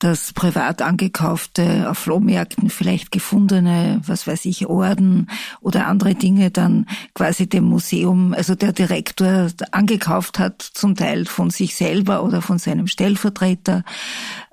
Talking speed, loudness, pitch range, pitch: 130 wpm, -18 LUFS, 180-200 Hz, 190 Hz